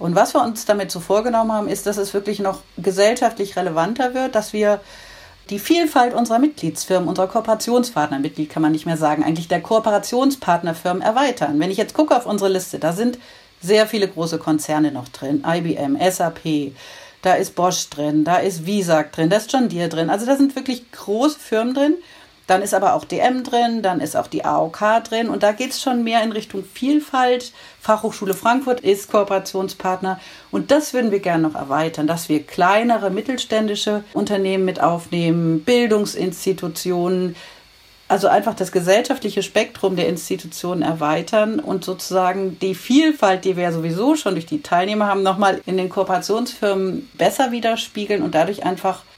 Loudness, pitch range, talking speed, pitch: -19 LUFS, 175-225 Hz, 170 wpm, 195 Hz